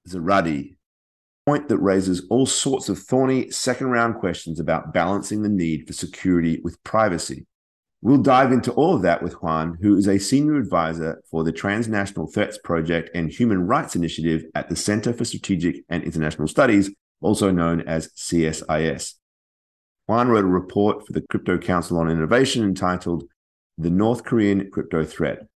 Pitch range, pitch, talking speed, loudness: 80-105 Hz, 90 Hz, 165 wpm, -21 LUFS